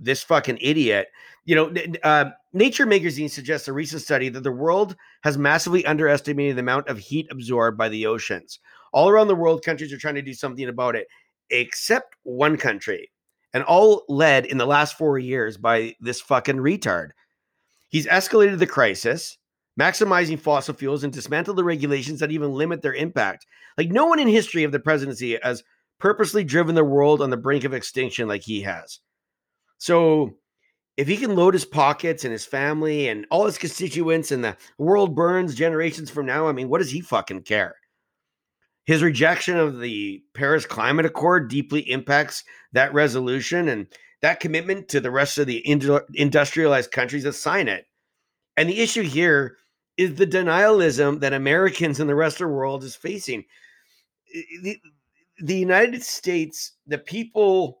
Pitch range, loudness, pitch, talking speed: 140-175 Hz, -21 LUFS, 150 Hz, 170 wpm